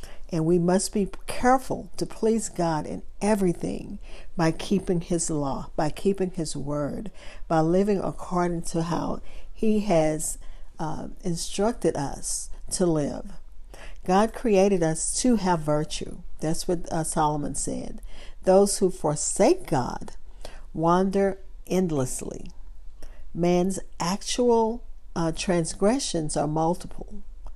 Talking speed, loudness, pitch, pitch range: 115 wpm, -26 LUFS, 175 Hz, 160-195 Hz